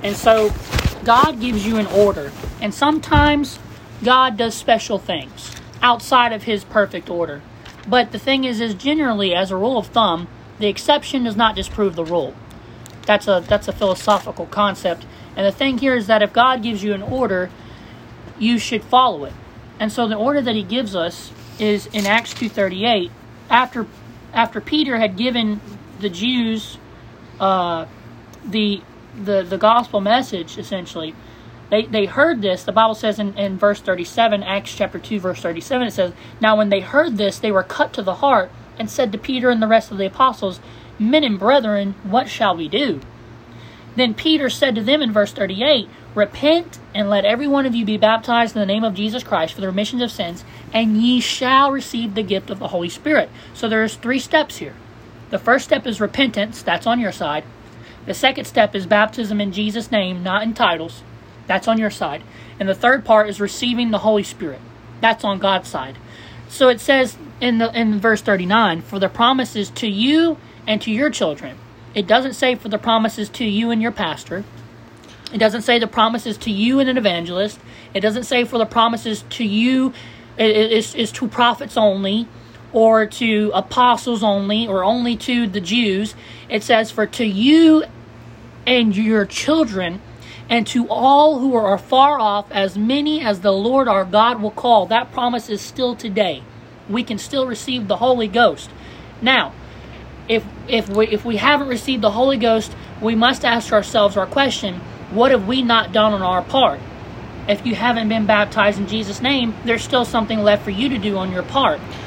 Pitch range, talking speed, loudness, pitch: 200-245 Hz, 190 wpm, -18 LUFS, 220 Hz